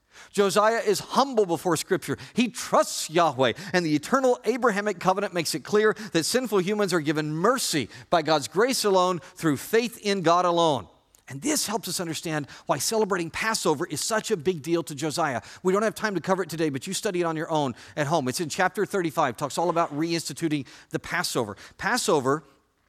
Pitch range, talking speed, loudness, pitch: 155-210 Hz, 195 wpm, -25 LUFS, 175 Hz